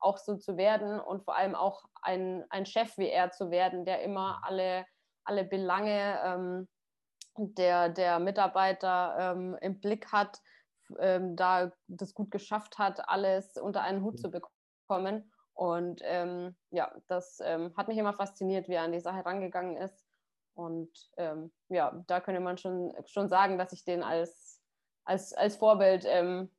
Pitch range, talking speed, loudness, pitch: 180-195 Hz, 165 wpm, -32 LUFS, 185 Hz